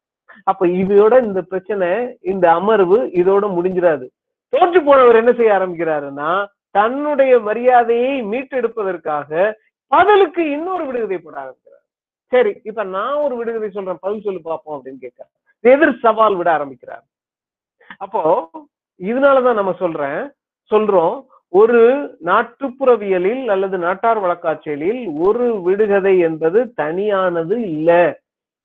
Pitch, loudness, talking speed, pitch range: 215 Hz, -16 LUFS, 105 wpm, 180-265 Hz